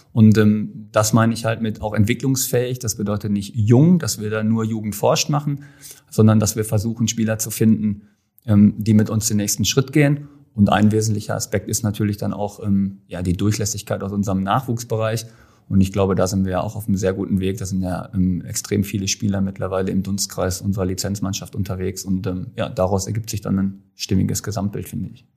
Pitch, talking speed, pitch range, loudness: 105 Hz, 210 wpm, 95-110 Hz, -20 LUFS